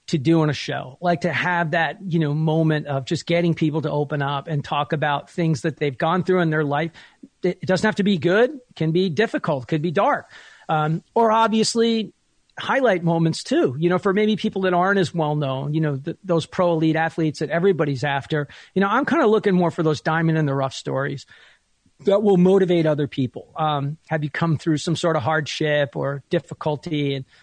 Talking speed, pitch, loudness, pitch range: 220 wpm, 165 Hz, -21 LUFS, 150-180 Hz